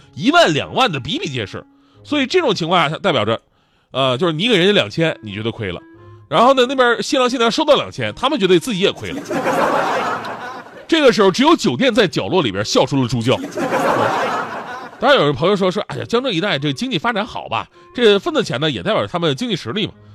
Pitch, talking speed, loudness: 200 Hz, 335 characters per minute, -17 LUFS